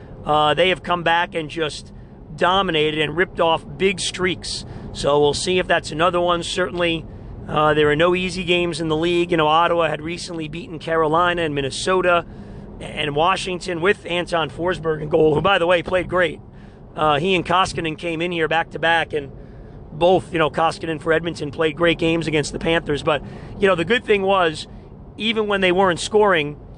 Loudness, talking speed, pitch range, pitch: -19 LUFS, 195 wpm, 150-180 Hz, 165 Hz